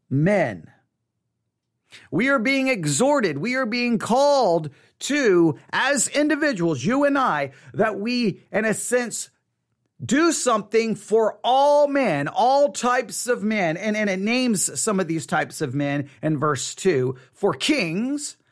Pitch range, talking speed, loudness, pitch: 165-265 Hz, 145 wpm, -21 LUFS, 215 Hz